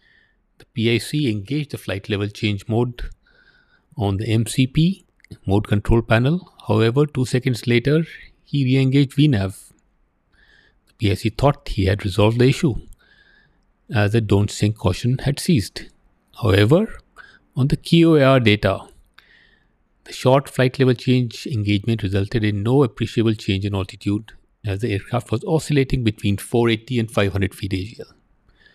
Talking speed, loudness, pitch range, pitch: 135 wpm, -20 LUFS, 105-135 Hz, 115 Hz